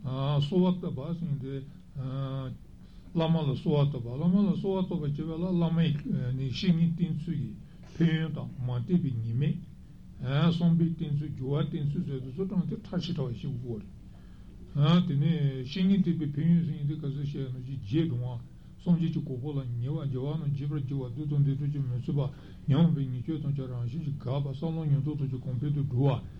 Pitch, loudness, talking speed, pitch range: 145 Hz, -30 LUFS, 165 wpm, 135-165 Hz